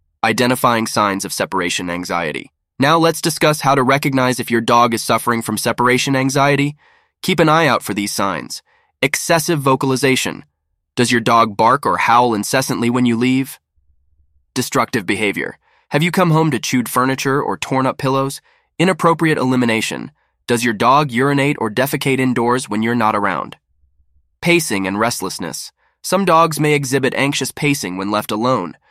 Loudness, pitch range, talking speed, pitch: -16 LUFS, 110-140 Hz, 160 wpm, 125 Hz